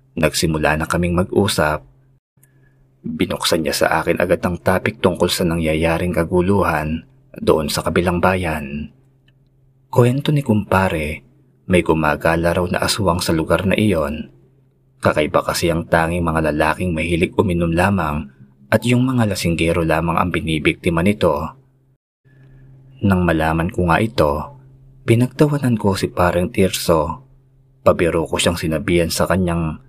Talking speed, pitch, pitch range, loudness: 130 wpm, 90 Hz, 85-130 Hz, -18 LUFS